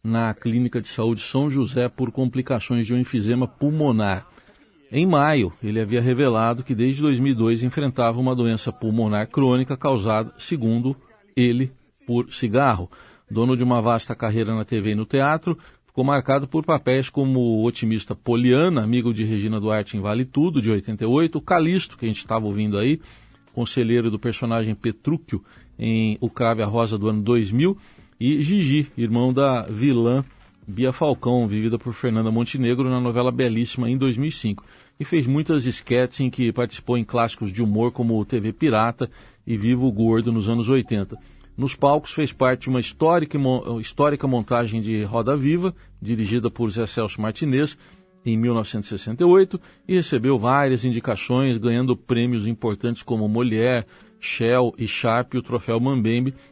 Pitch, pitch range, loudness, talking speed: 120 Hz, 115-135 Hz, -22 LUFS, 160 wpm